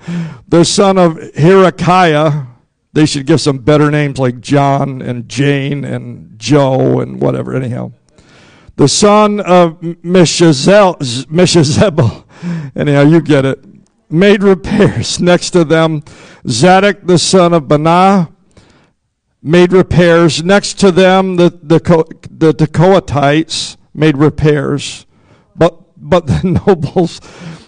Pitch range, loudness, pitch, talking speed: 145-180 Hz, -10 LUFS, 165 Hz, 115 wpm